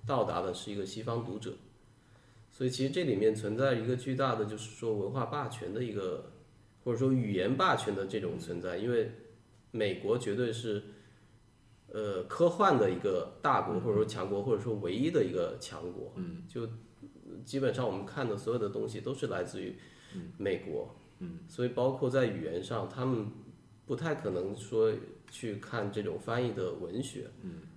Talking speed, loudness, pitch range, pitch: 265 characters per minute, -34 LUFS, 110-155 Hz, 125 Hz